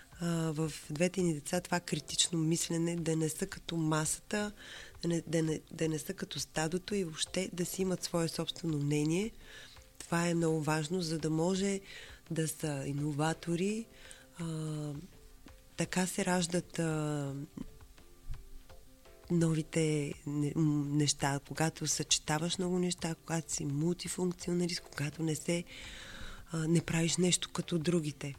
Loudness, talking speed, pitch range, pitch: -34 LUFS, 130 wpm, 155-175 Hz, 165 Hz